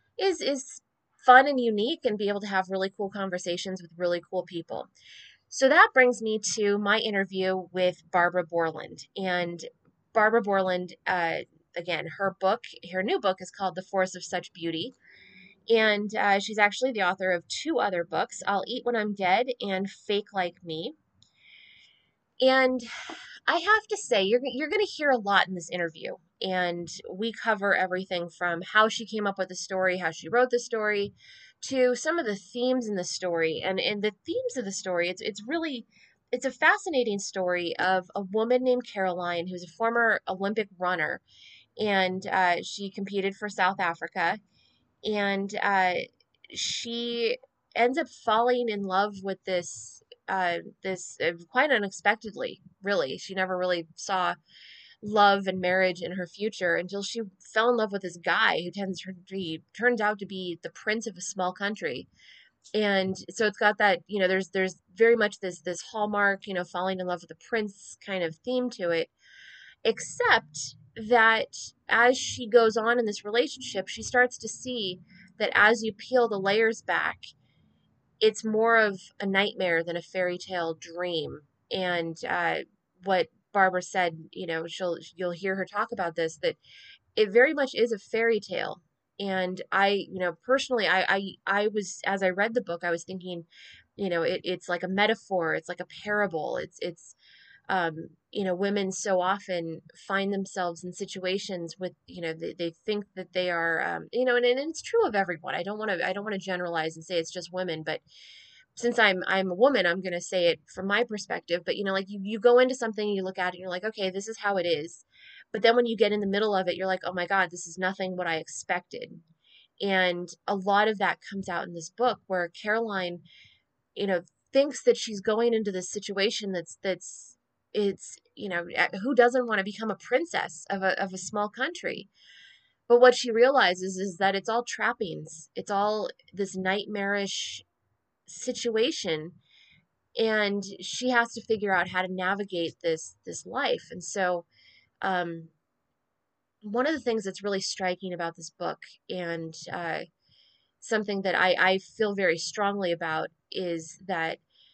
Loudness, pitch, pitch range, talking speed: -27 LUFS, 195 Hz, 180-220 Hz, 185 wpm